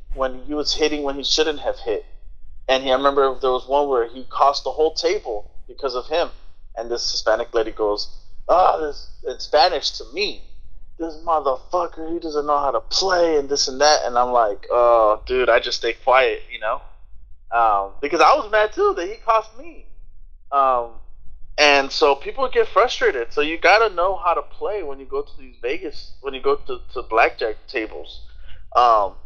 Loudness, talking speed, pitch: -20 LUFS, 200 wpm, 150 Hz